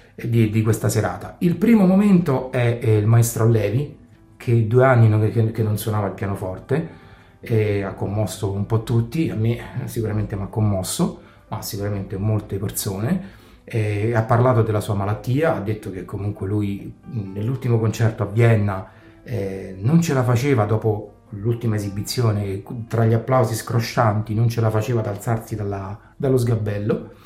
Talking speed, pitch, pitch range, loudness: 165 wpm, 110 Hz, 105-120 Hz, -21 LUFS